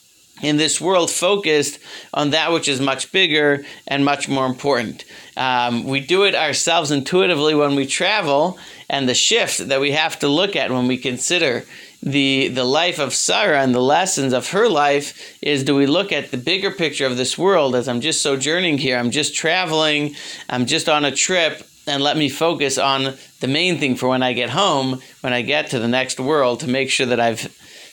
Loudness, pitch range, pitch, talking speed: -18 LUFS, 130-155 Hz, 140 Hz, 205 wpm